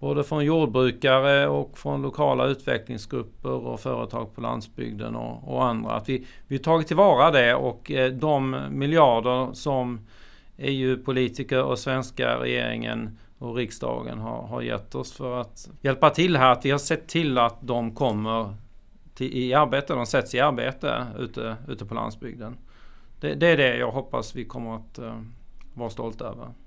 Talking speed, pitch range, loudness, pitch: 160 wpm, 110-135 Hz, -24 LUFS, 125 Hz